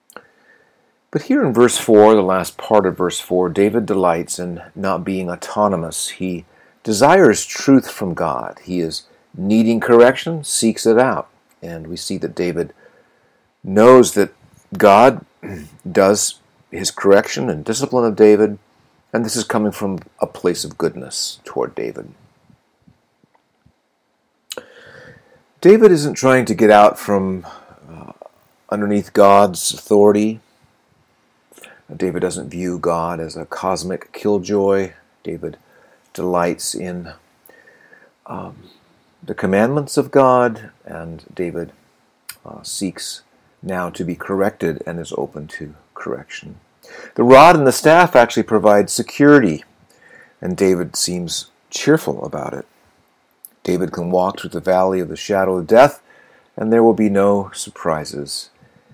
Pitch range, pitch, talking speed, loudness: 90-115 Hz, 100 Hz, 130 wpm, -15 LUFS